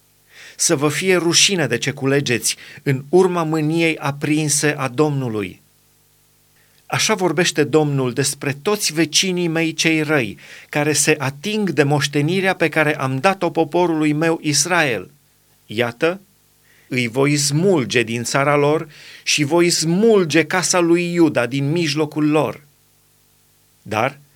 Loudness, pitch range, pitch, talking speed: -17 LUFS, 140-170 Hz, 155 Hz, 125 wpm